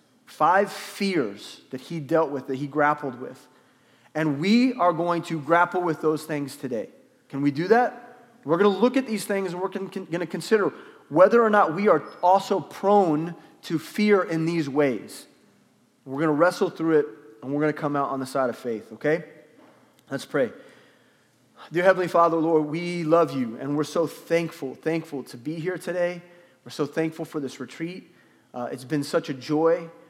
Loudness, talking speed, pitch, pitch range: -24 LUFS, 190 wpm, 165 Hz, 150-180 Hz